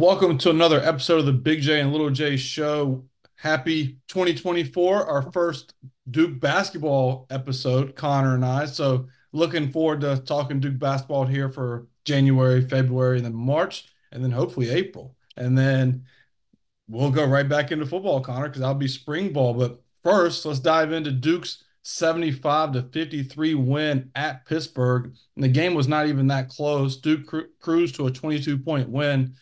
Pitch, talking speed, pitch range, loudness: 140 Hz, 170 wpm, 130-155 Hz, -23 LUFS